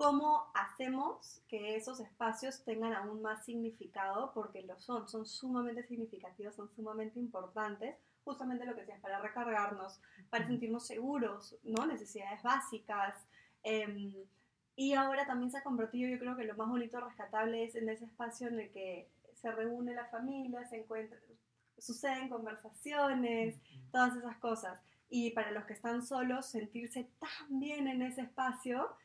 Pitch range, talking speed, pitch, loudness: 215-250 Hz, 150 wpm, 230 Hz, -40 LUFS